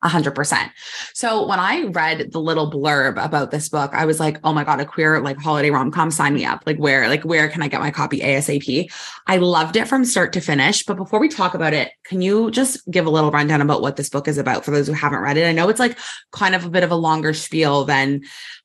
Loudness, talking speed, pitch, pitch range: -18 LUFS, 255 wpm, 155 Hz, 145-175 Hz